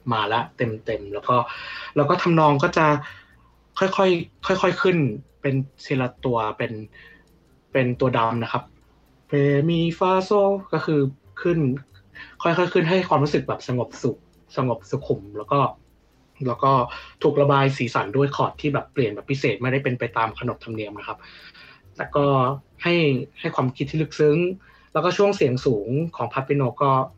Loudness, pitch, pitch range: -22 LUFS, 140 Hz, 125-165 Hz